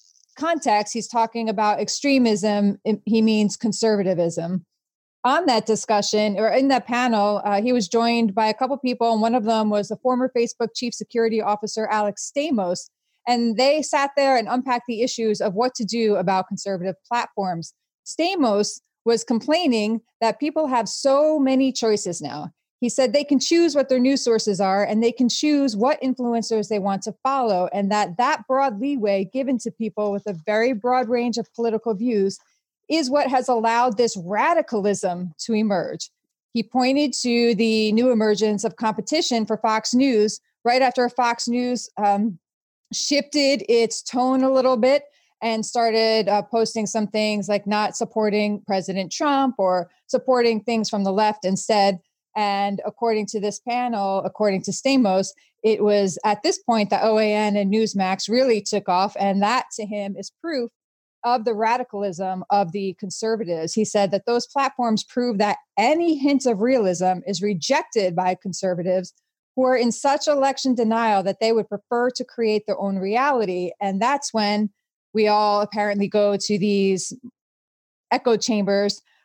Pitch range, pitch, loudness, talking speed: 205-250 Hz, 225 Hz, -21 LUFS, 165 wpm